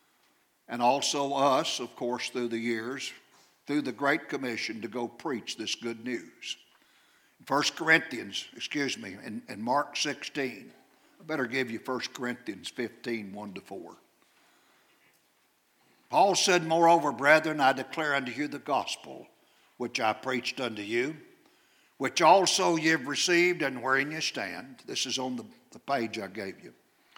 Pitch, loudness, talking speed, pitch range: 130 Hz, -29 LUFS, 150 wpm, 120-155 Hz